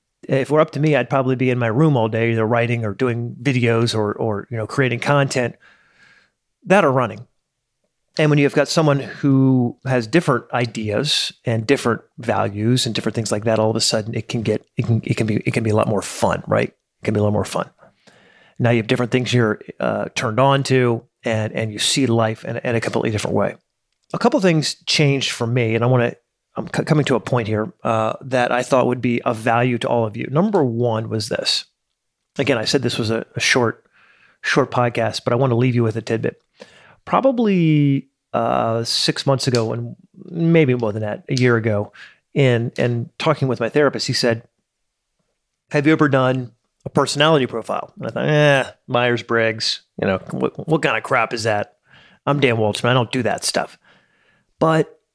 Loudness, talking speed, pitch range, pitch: -19 LUFS, 215 wpm, 115-140 Hz, 125 Hz